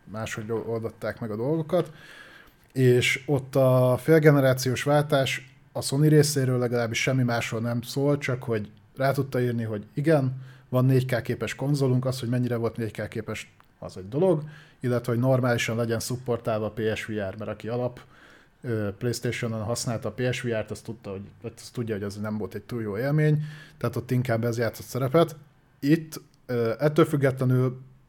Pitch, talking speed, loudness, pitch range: 125 Hz, 150 wpm, -26 LUFS, 115-135 Hz